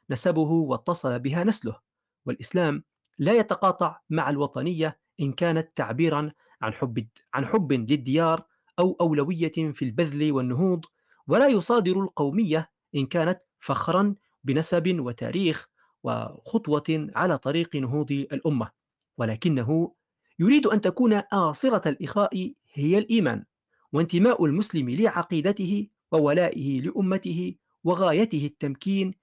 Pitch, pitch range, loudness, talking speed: 165 Hz, 145-190 Hz, -25 LUFS, 105 wpm